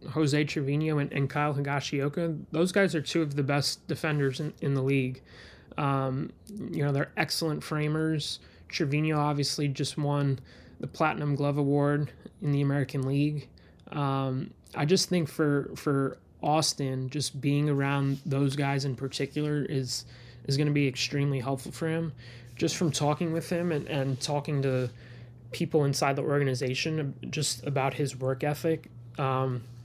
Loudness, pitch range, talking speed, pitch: -29 LUFS, 135-150 Hz, 155 wpm, 145 Hz